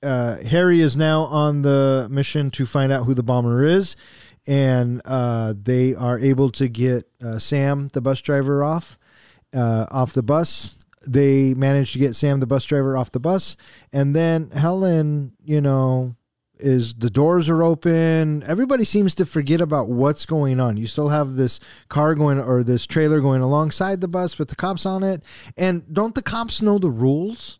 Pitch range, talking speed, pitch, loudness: 130-160 Hz, 185 wpm, 140 Hz, -20 LUFS